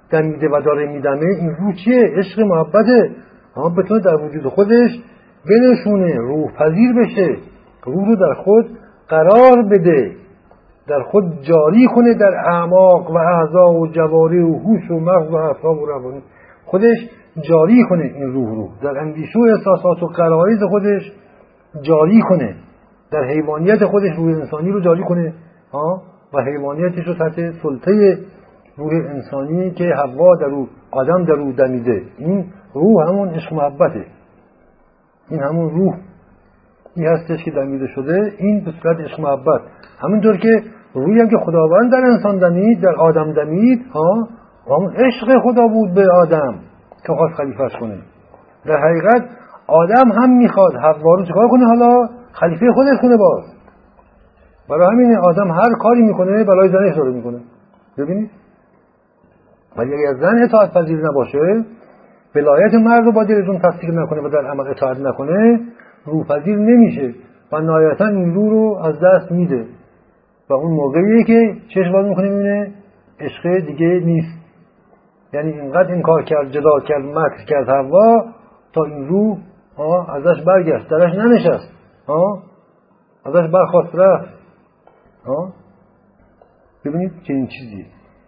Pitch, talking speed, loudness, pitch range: 180 Hz, 145 wpm, -14 LUFS, 155-210 Hz